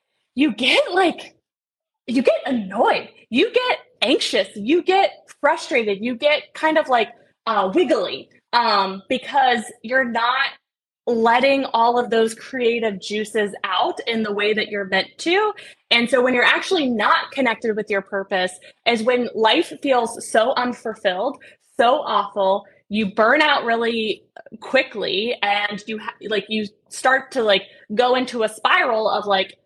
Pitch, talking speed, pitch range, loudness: 235 Hz, 150 wpm, 215-270 Hz, -19 LUFS